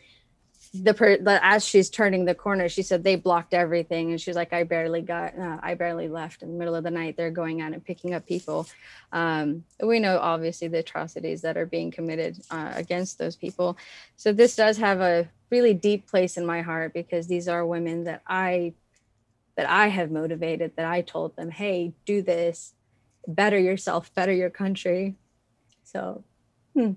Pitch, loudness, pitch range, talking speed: 175 Hz, -25 LUFS, 165-190 Hz, 185 wpm